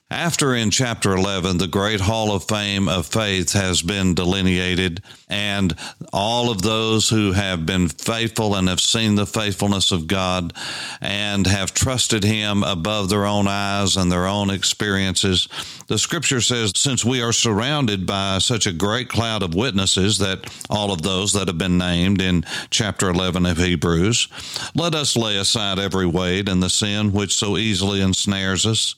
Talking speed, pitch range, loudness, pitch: 170 wpm, 95-110 Hz, -19 LUFS, 100 Hz